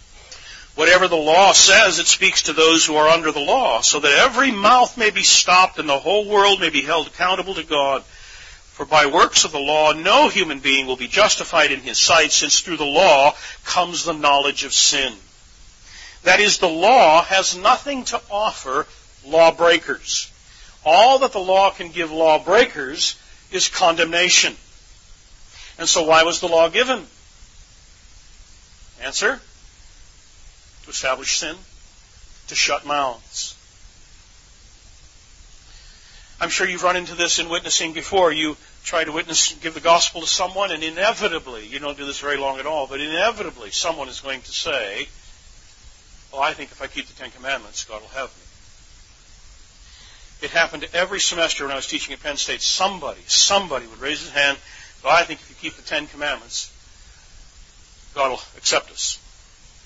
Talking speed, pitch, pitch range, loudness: 165 wpm, 155 Hz, 130-180 Hz, -17 LUFS